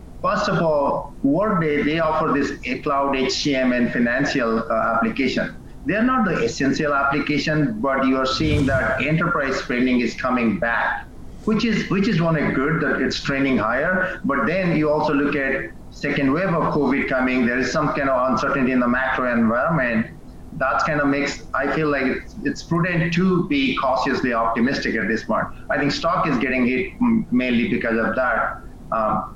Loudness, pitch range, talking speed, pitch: -20 LUFS, 130-165 Hz, 180 wpm, 140 Hz